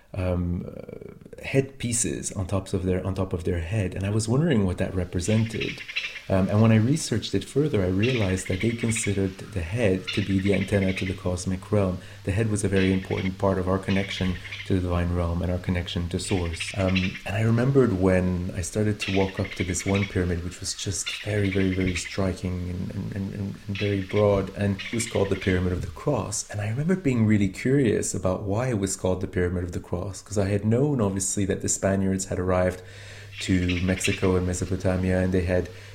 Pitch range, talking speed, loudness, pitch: 95-105 Hz, 215 wpm, -25 LUFS, 95 Hz